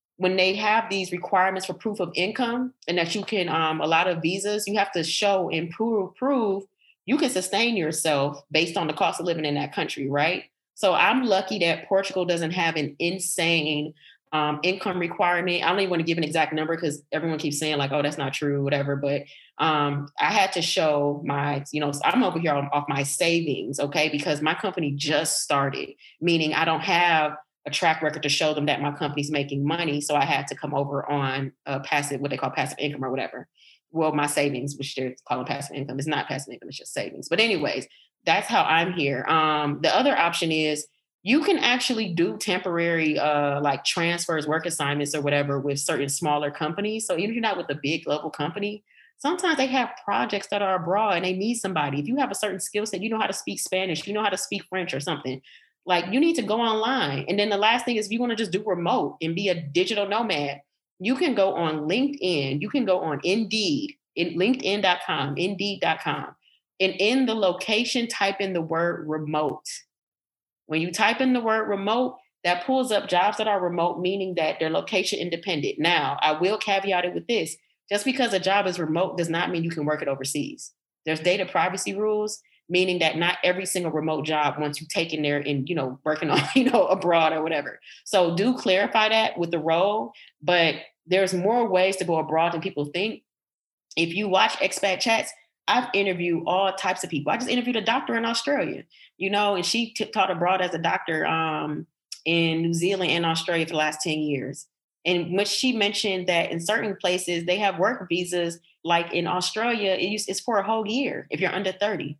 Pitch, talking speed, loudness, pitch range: 175 Hz, 210 wpm, -24 LUFS, 155-200 Hz